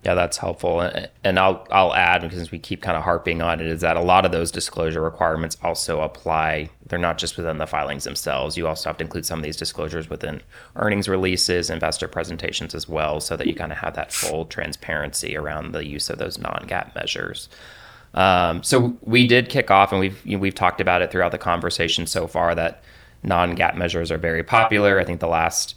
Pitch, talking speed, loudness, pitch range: 85 Hz, 215 wpm, -21 LUFS, 80-95 Hz